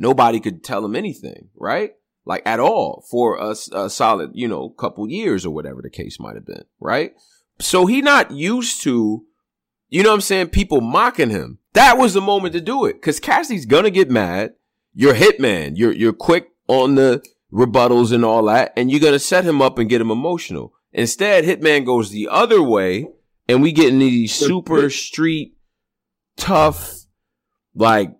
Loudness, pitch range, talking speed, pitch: -16 LUFS, 120-195 Hz, 185 wpm, 145 Hz